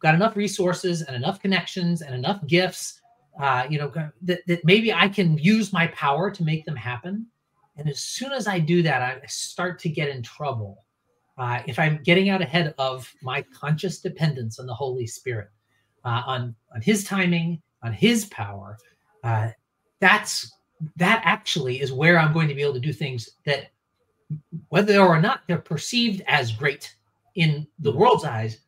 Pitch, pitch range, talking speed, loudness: 155 Hz, 130-180 Hz, 180 wpm, -23 LUFS